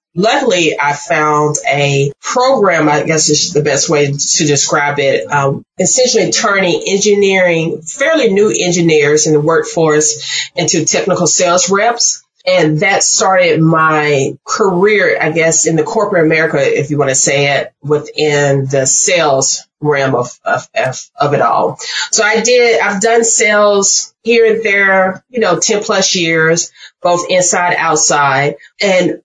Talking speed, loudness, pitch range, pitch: 150 wpm, -11 LUFS, 150-200 Hz, 160 Hz